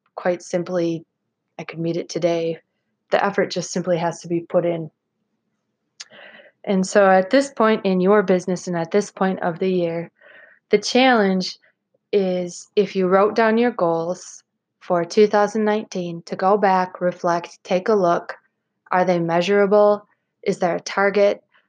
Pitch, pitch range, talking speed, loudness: 185 Hz, 175-205 Hz, 155 wpm, -20 LUFS